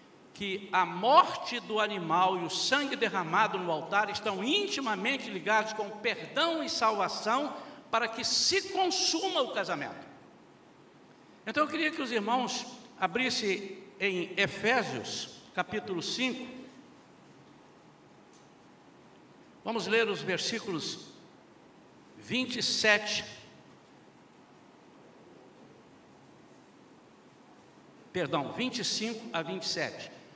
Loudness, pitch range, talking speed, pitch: -30 LUFS, 195-255 Hz, 85 wpm, 220 Hz